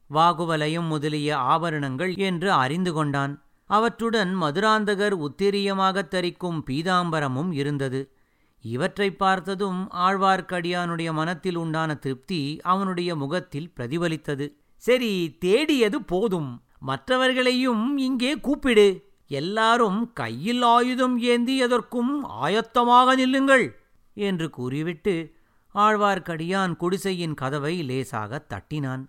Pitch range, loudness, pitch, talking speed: 150-210 Hz, -23 LUFS, 180 Hz, 85 wpm